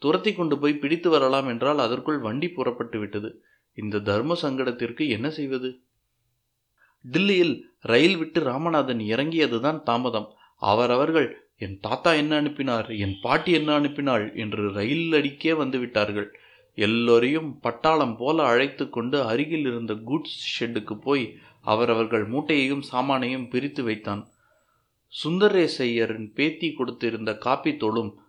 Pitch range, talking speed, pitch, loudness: 115-150 Hz, 110 wpm, 130 Hz, -24 LUFS